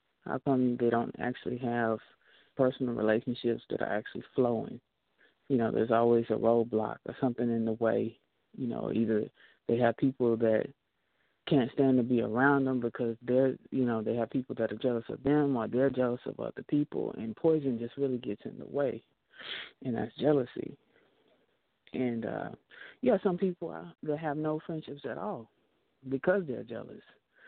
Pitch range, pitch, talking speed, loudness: 115-140 Hz, 125 Hz, 175 wpm, -31 LUFS